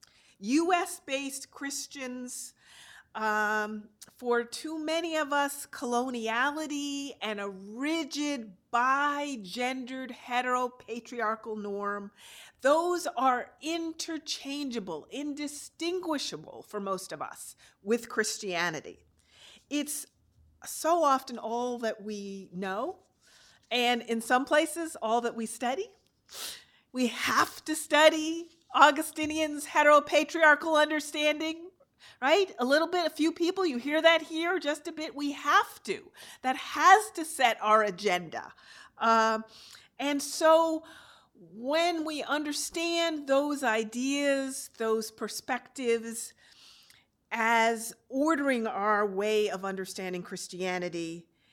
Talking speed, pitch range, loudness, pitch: 100 wpm, 225-310 Hz, -29 LUFS, 270 Hz